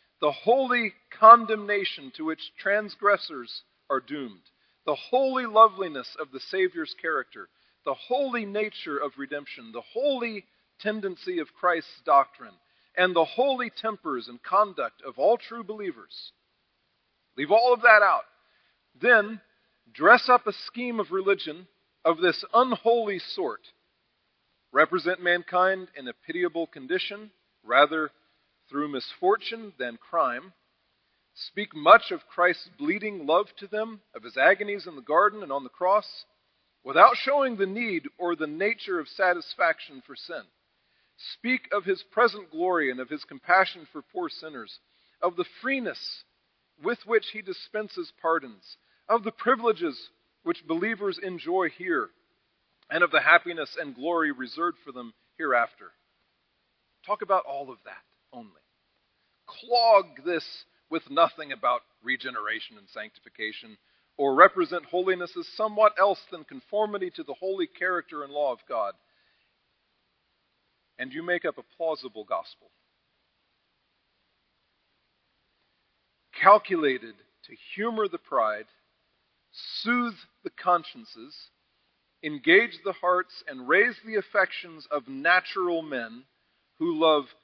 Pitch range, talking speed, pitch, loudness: 170-240 Hz, 125 wpm, 200 Hz, -25 LUFS